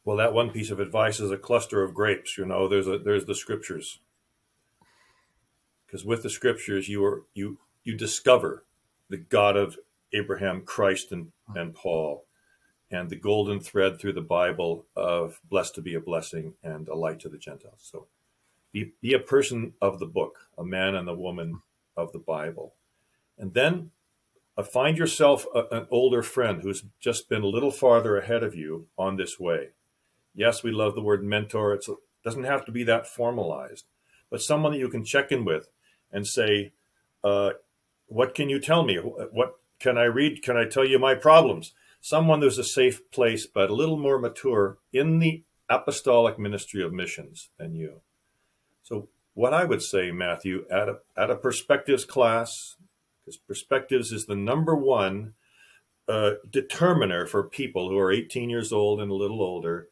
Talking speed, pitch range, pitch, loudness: 180 wpm, 100-135 Hz, 110 Hz, -25 LUFS